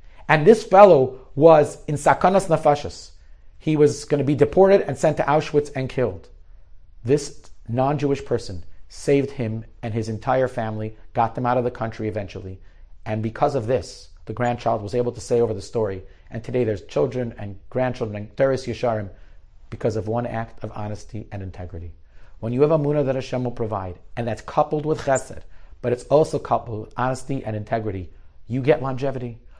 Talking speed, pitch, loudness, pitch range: 180 wpm, 120 Hz, -21 LUFS, 105-135 Hz